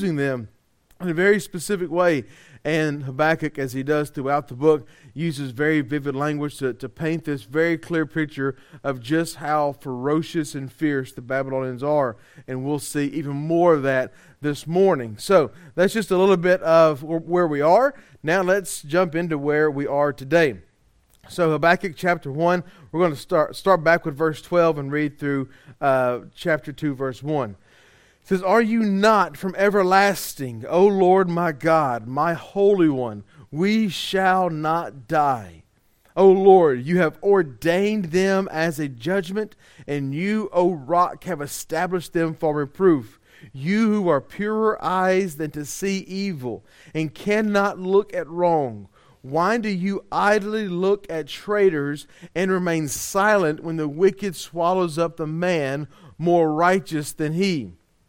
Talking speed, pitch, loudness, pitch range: 155 wpm, 160 Hz, -21 LUFS, 145-185 Hz